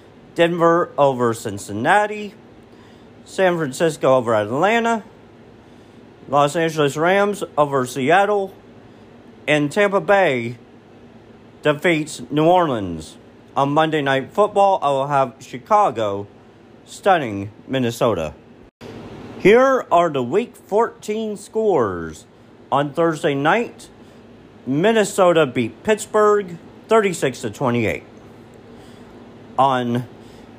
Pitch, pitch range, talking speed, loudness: 150 Hz, 120-195 Hz, 85 wpm, -18 LUFS